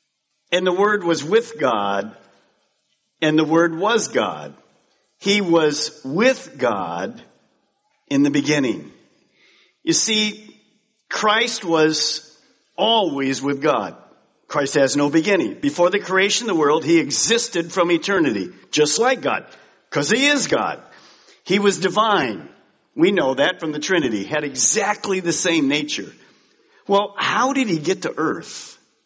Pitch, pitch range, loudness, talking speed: 180 Hz, 155-215 Hz, -19 LUFS, 140 wpm